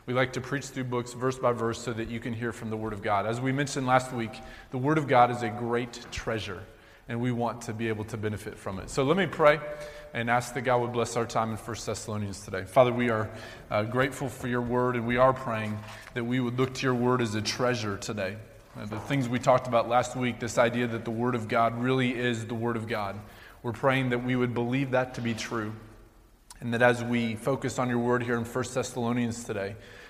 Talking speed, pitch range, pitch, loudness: 250 wpm, 110-125 Hz, 120 Hz, -28 LUFS